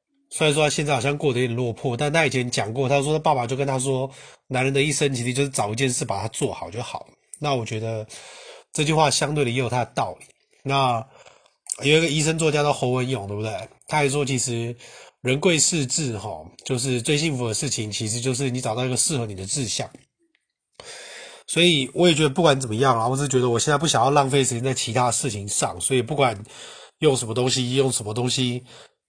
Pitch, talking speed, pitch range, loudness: 135 Hz, 330 characters per minute, 125-150 Hz, -22 LUFS